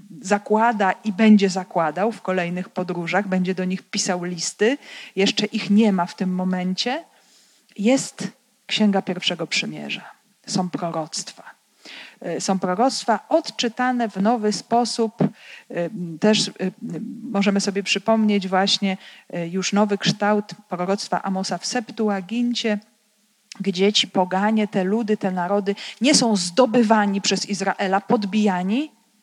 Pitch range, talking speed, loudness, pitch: 185-220 Hz, 115 wpm, -21 LUFS, 205 Hz